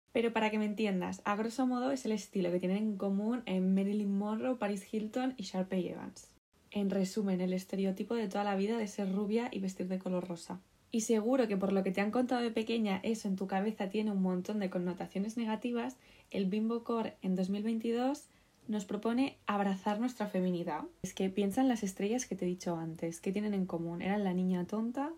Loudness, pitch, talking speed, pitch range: -35 LUFS, 205 Hz, 210 wpm, 190-225 Hz